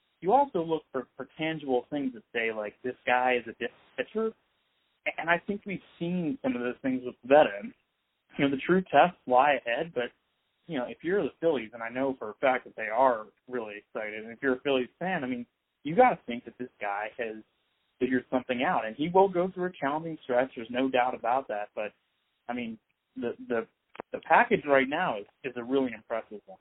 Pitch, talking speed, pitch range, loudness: 130 Hz, 220 wpm, 120-170 Hz, -29 LUFS